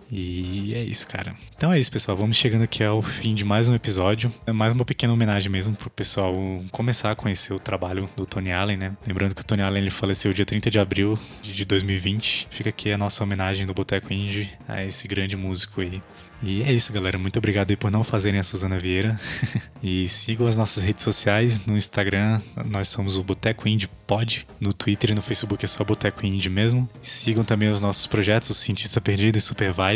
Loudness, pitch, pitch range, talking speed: -24 LUFS, 105 Hz, 95-110 Hz, 215 wpm